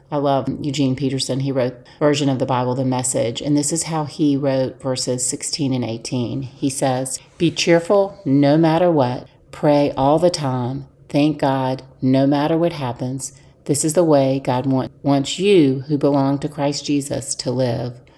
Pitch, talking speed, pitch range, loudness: 140 Hz, 180 wpm, 130-145 Hz, -19 LUFS